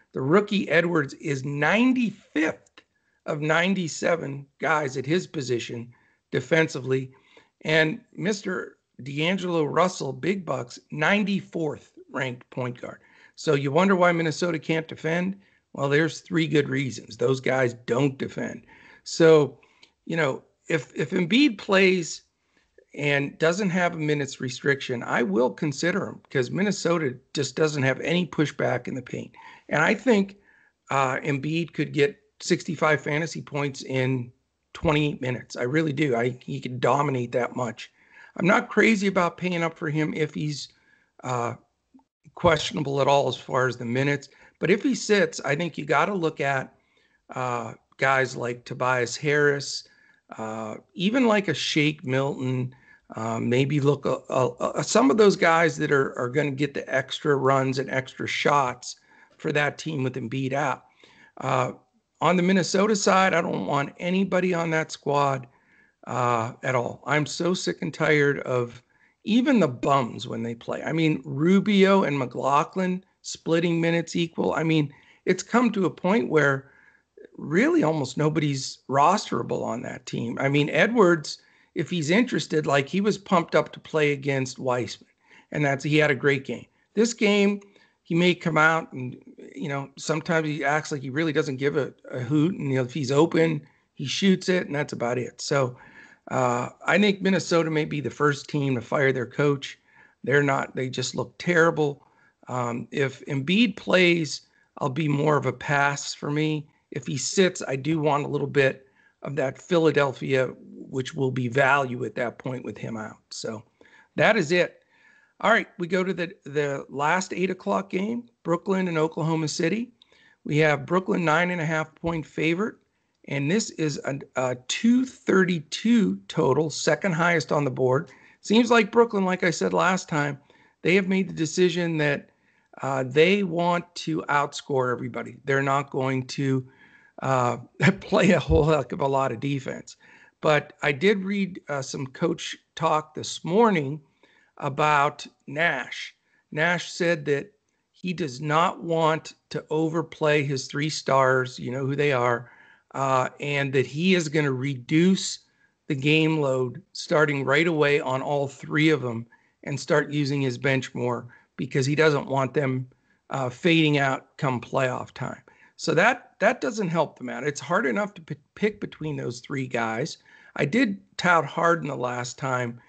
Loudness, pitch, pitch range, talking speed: -24 LUFS, 150 Hz, 135-175 Hz, 165 wpm